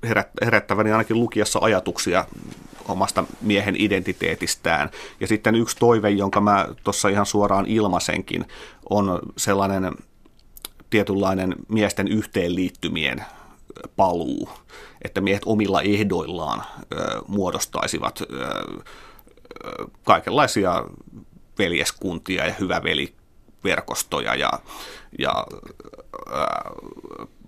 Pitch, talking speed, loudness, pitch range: 100 Hz, 75 wpm, -22 LUFS, 95-110 Hz